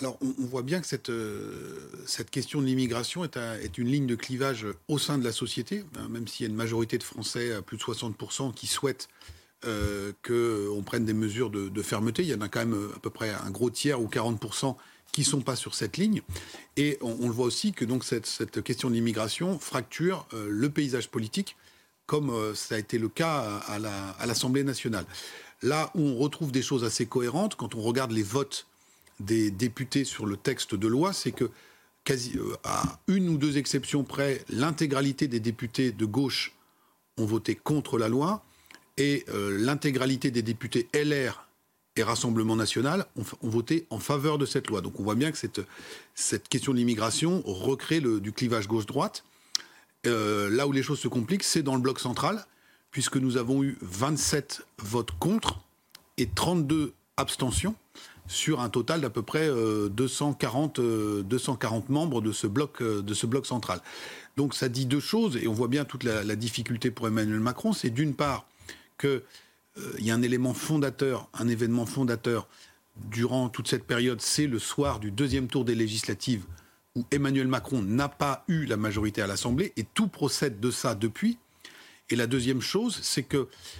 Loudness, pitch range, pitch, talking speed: -29 LUFS, 110-140 Hz, 125 Hz, 190 wpm